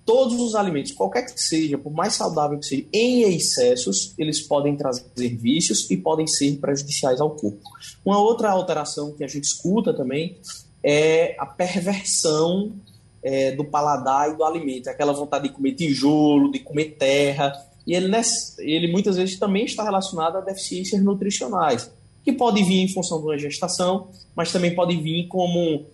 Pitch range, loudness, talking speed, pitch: 145-190 Hz, -22 LUFS, 165 wpm, 160 Hz